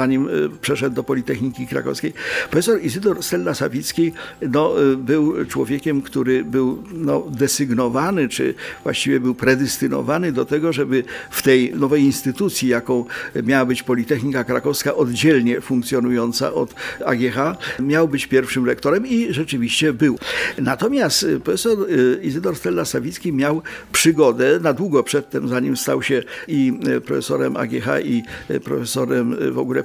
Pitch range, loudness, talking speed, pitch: 130-155 Hz, -19 LUFS, 125 wpm, 135 Hz